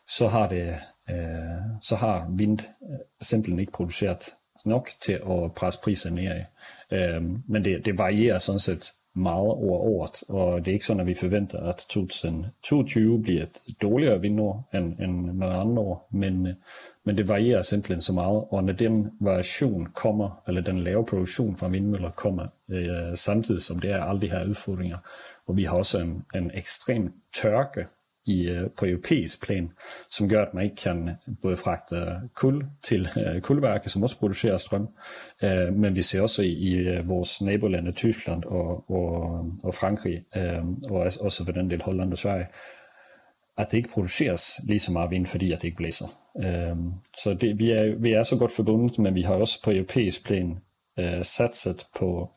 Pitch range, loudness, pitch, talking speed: 90-105 Hz, -26 LUFS, 95 Hz, 175 wpm